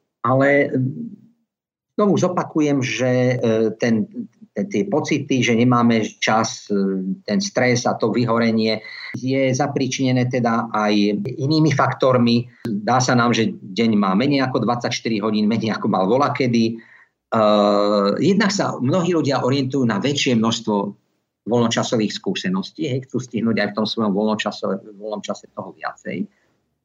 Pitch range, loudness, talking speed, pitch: 110-140 Hz, -19 LUFS, 125 wpm, 125 Hz